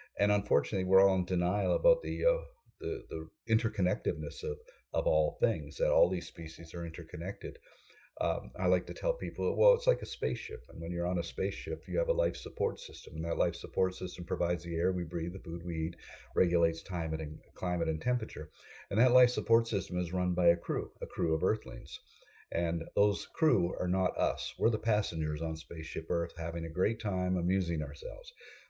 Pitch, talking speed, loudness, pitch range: 90 Hz, 205 wpm, -32 LUFS, 85-110 Hz